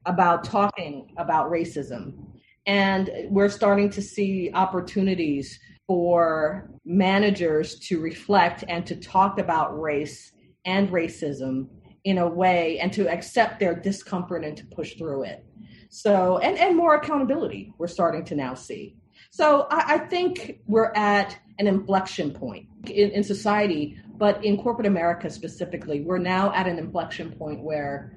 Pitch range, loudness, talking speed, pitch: 165-205 Hz, -24 LUFS, 145 wpm, 185 Hz